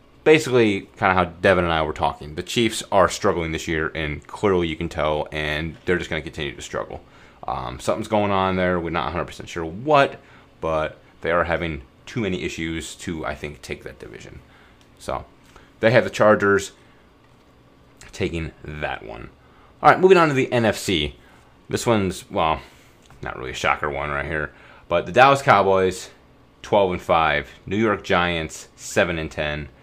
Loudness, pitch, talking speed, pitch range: -21 LUFS, 85 Hz, 180 wpm, 80-100 Hz